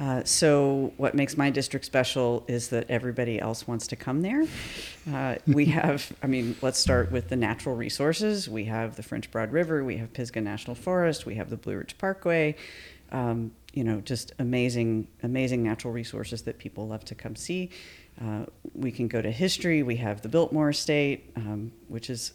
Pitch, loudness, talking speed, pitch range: 125 Hz, -28 LUFS, 190 wpm, 115-145 Hz